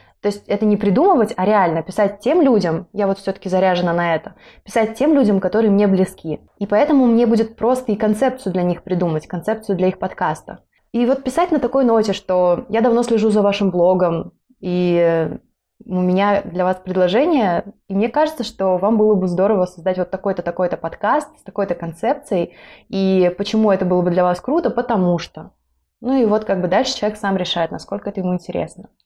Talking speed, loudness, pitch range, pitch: 195 wpm, -18 LUFS, 180-225 Hz, 200 Hz